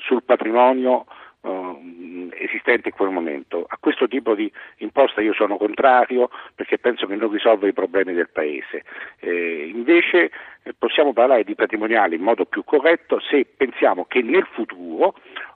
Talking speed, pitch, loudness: 155 wpm, 125 Hz, -19 LUFS